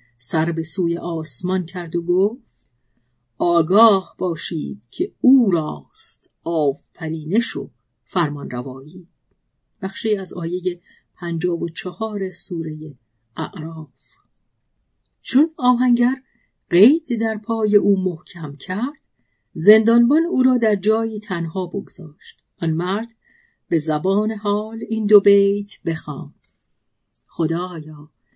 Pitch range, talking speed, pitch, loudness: 160-215 Hz, 105 wpm, 180 Hz, -20 LUFS